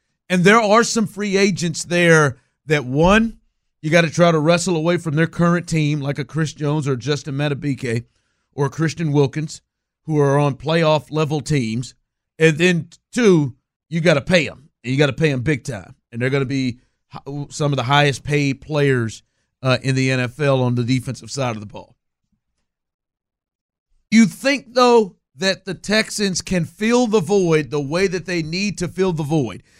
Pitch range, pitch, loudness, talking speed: 130-175 Hz, 150 Hz, -18 LUFS, 185 wpm